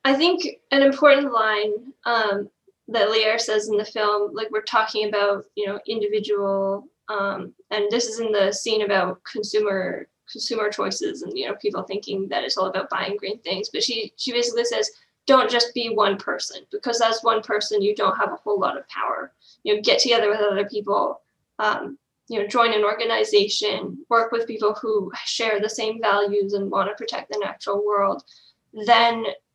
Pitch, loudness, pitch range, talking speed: 215 Hz, -22 LUFS, 205-235 Hz, 190 wpm